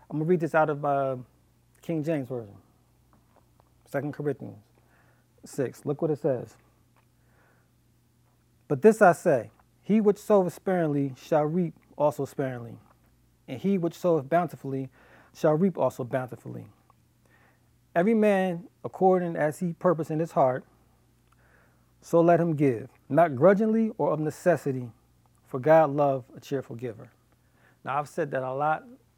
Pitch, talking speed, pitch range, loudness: 150 Hz, 140 wpm, 130-170 Hz, -26 LUFS